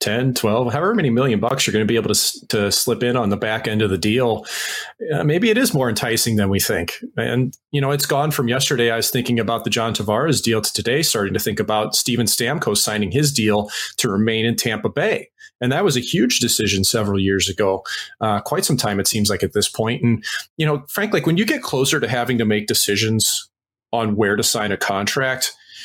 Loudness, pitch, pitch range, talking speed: -19 LUFS, 115 Hz, 105-135 Hz, 230 wpm